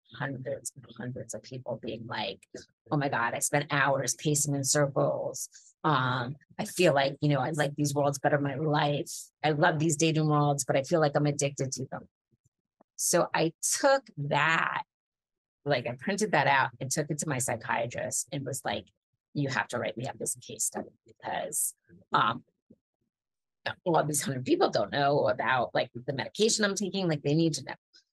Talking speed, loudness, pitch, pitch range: 195 wpm, -29 LUFS, 145 Hz, 135-160 Hz